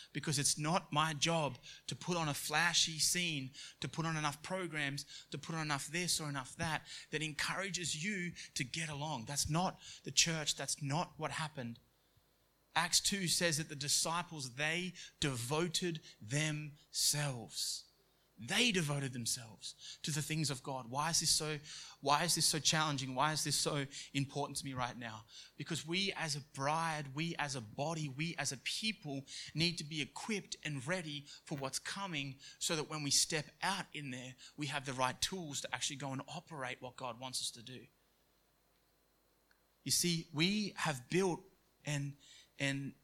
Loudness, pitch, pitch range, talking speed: -37 LUFS, 150 Hz, 140-165 Hz, 175 wpm